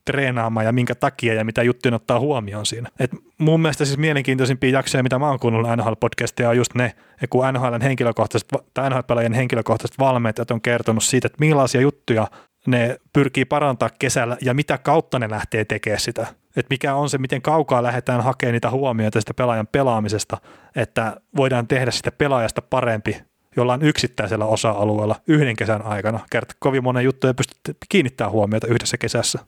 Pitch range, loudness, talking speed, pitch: 115-135 Hz, -20 LUFS, 170 wpm, 125 Hz